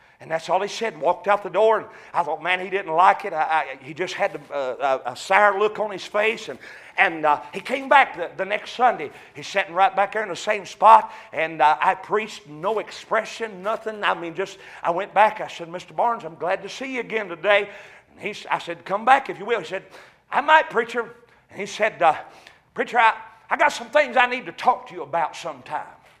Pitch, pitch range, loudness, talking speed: 205 Hz, 175-225 Hz, -22 LUFS, 240 wpm